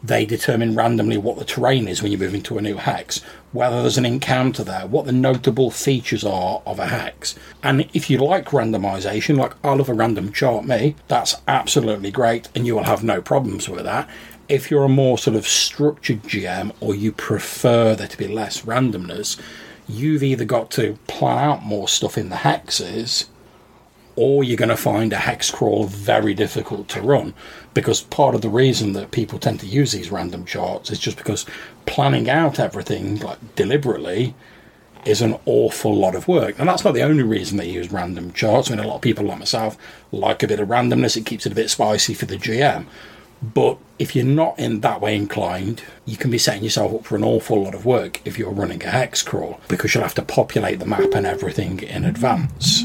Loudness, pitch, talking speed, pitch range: -20 LUFS, 110 Hz, 210 wpm, 105-130 Hz